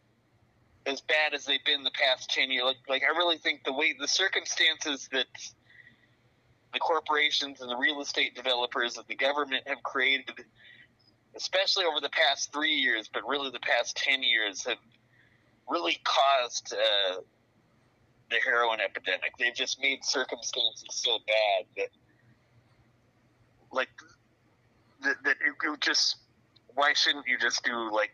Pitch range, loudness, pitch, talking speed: 120-145 Hz, -27 LUFS, 130 Hz, 145 wpm